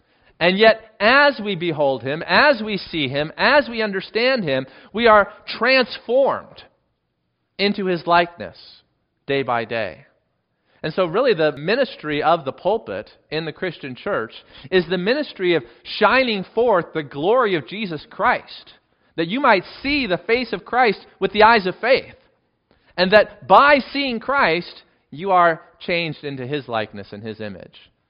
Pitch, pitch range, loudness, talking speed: 185 Hz, 150-225 Hz, -19 LUFS, 155 wpm